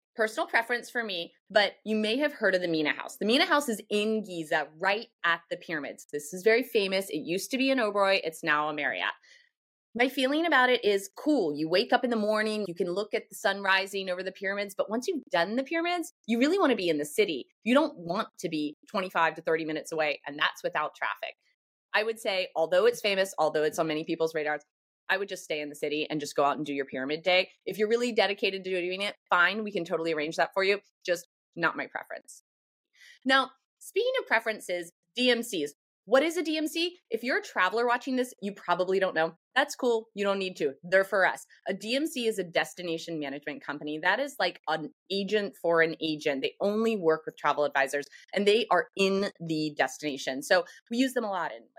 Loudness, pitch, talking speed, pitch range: -28 LUFS, 195 Hz, 225 wpm, 165-240 Hz